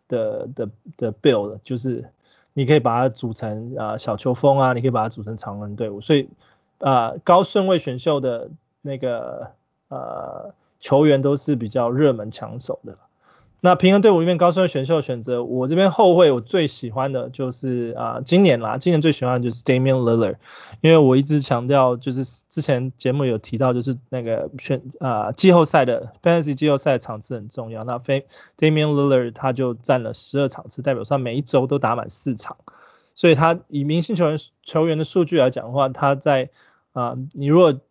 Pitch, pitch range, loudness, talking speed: 135 Hz, 120-155 Hz, -19 LUFS, 330 characters per minute